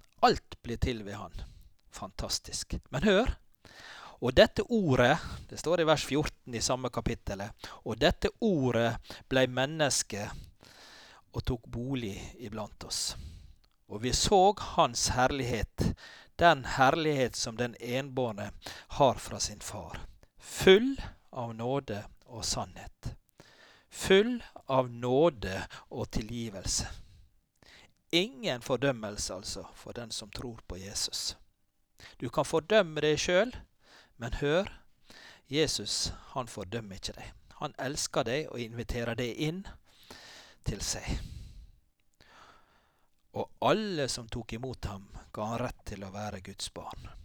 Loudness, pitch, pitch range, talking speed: -31 LUFS, 120 Hz, 105-135 Hz, 125 wpm